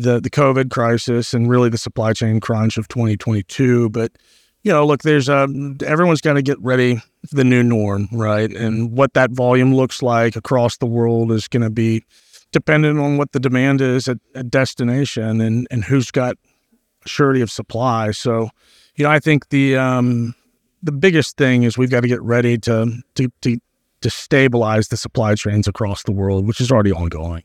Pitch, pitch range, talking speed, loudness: 120 Hz, 115-135 Hz, 190 wpm, -17 LUFS